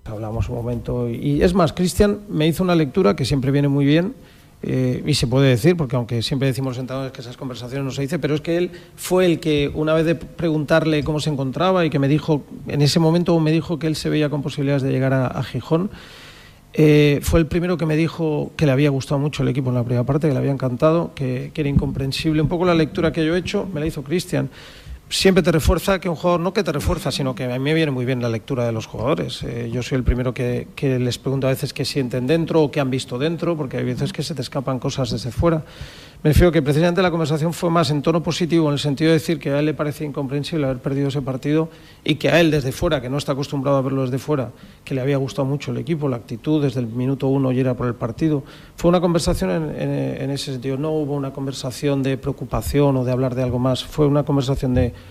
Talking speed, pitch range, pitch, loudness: 260 wpm, 130-160 Hz, 145 Hz, -20 LUFS